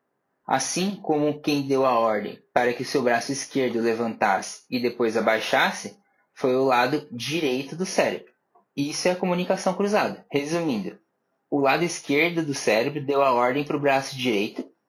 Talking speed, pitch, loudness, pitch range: 160 wpm, 140 Hz, -24 LUFS, 125-160 Hz